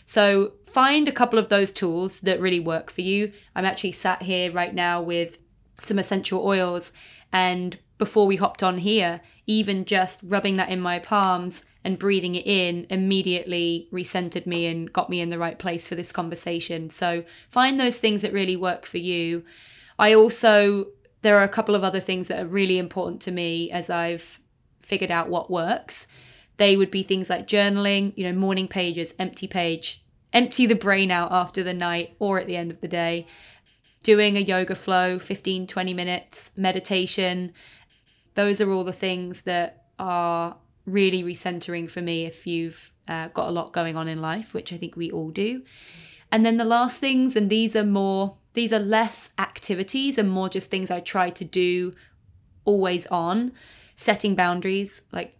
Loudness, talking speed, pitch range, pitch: -23 LUFS, 185 wpm, 175-200 Hz, 185 Hz